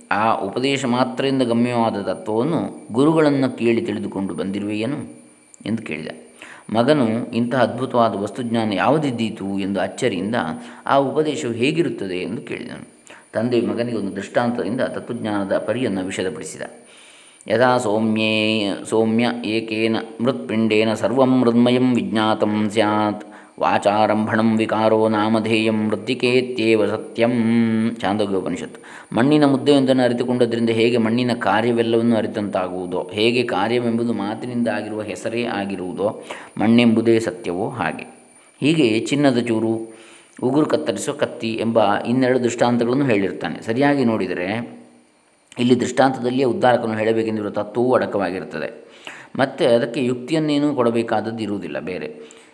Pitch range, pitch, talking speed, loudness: 105-125 Hz, 115 Hz, 95 wpm, -20 LUFS